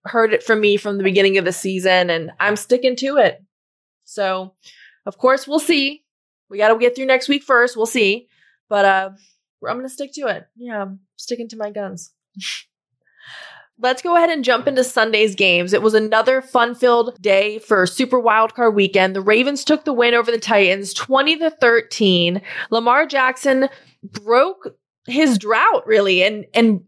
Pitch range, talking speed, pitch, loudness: 195-255 Hz, 180 wpm, 225 Hz, -16 LUFS